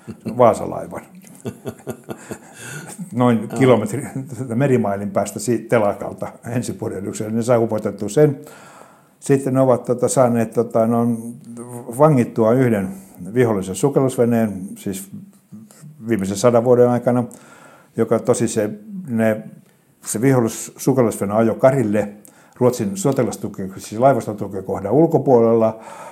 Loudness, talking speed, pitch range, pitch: -18 LUFS, 95 wpm, 110-130 Hz, 120 Hz